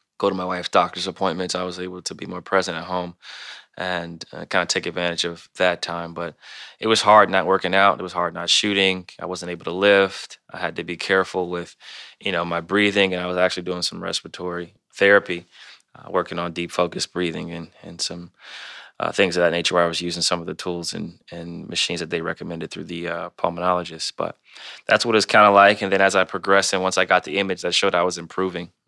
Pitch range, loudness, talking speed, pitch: 85-95 Hz, -21 LUFS, 240 wpm, 90 Hz